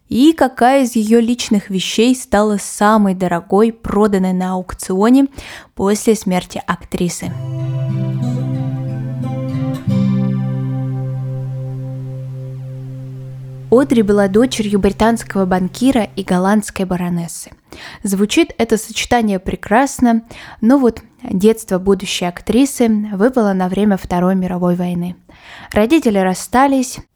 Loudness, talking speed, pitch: -15 LUFS, 90 wpm, 195 Hz